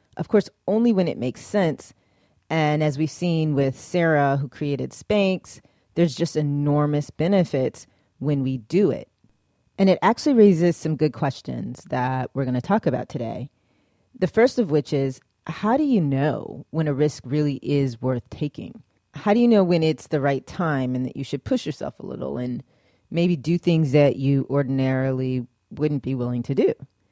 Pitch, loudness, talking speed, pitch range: 145 Hz, -23 LUFS, 185 wpm, 130-170 Hz